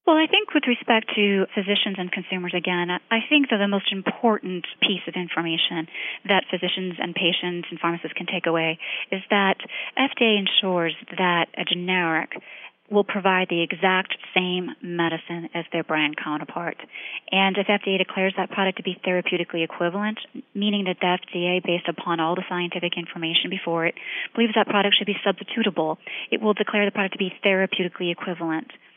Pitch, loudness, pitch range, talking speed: 185 Hz, -23 LUFS, 175-205 Hz, 170 wpm